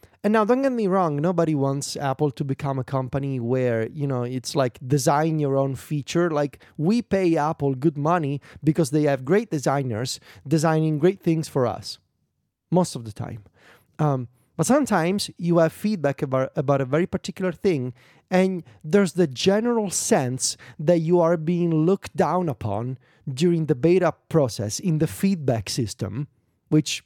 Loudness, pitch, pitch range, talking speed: -23 LUFS, 150 Hz, 130-175 Hz, 165 wpm